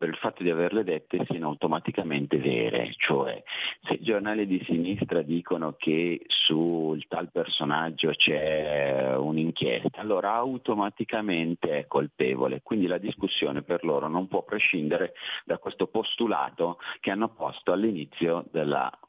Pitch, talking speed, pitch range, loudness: 85 Hz, 130 wpm, 75-95 Hz, -27 LUFS